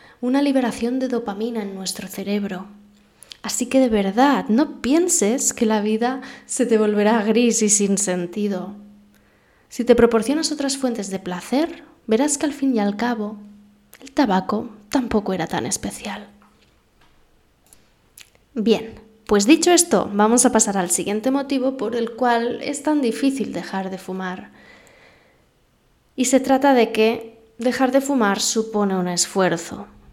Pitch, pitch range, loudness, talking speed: 225 Hz, 205-260 Hz, -20 LUFS, 145 wpm